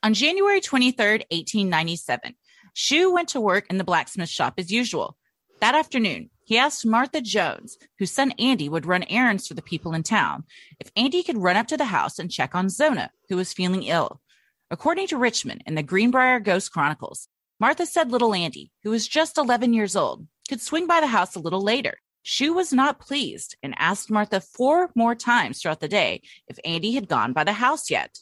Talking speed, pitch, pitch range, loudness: 200 wpm, 230 Hz, 185-280 Hz, -22 LUFS